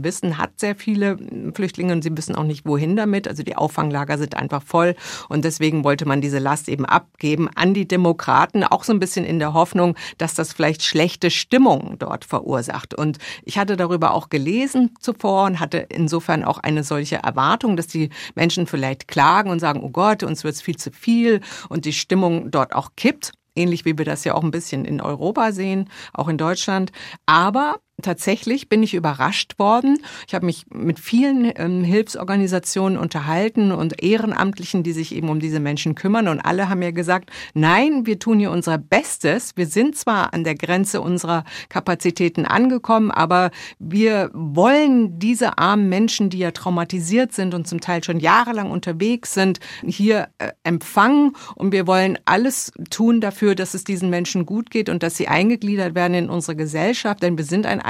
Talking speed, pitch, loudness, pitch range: 185 wpm, 180 Hz, -19 LUFS, 165-205 Hz